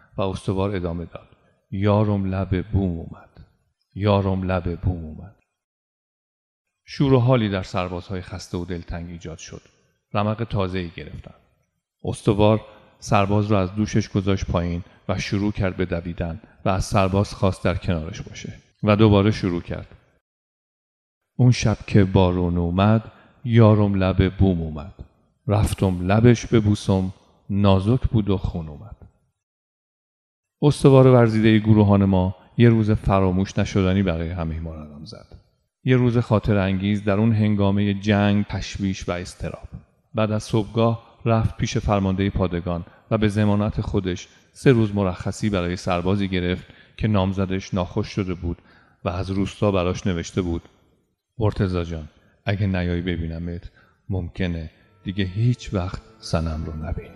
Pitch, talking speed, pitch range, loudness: 100 Hz, 140 wpm, 90-105 Hz, -22 LUFS